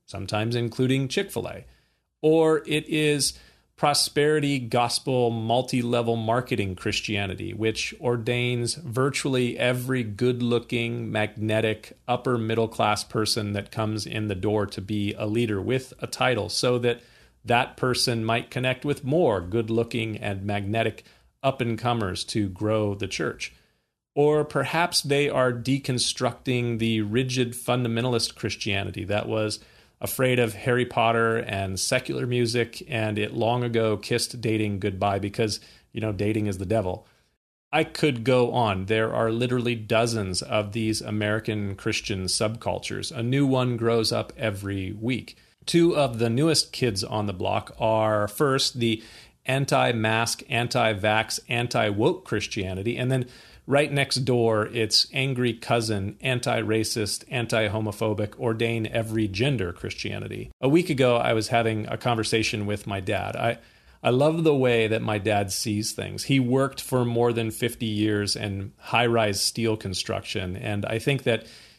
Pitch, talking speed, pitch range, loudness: 115 Hz, 145 wpm, 110-125 Hz, -25 LUFS